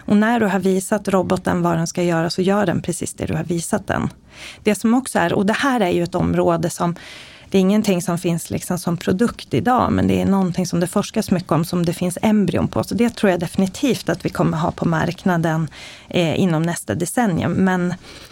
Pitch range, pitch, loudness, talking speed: 170-205 Hz, 180 Hz, -19 LUFS, 230 wpm